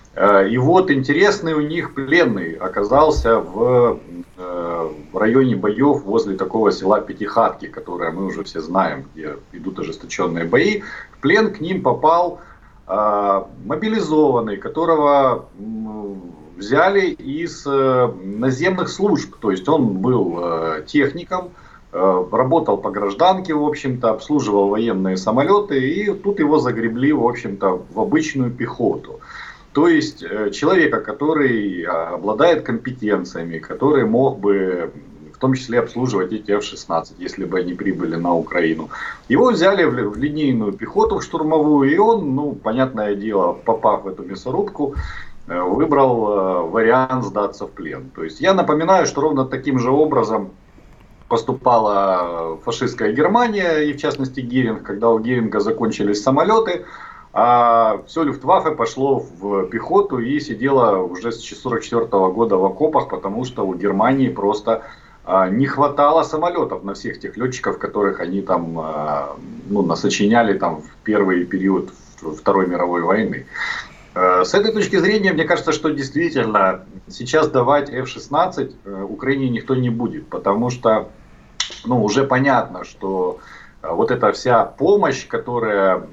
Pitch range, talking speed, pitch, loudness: 100-150 Hz, 130 wpm, 120 Hz, -18 LUFS